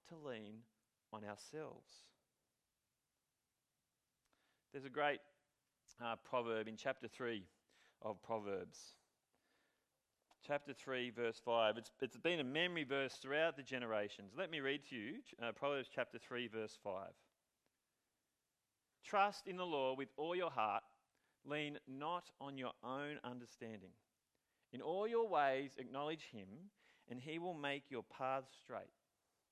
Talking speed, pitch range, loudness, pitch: 130 wpm, 115-145 Hz, -44 LUFS, 135 Hz